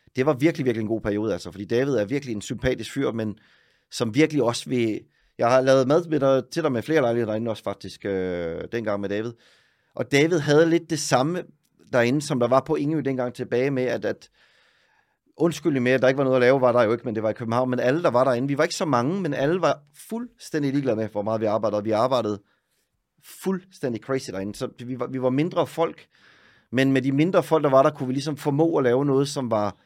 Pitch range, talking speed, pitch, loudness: 115-150 Hz, 245 wpm, 130 Hz, -23 LUFS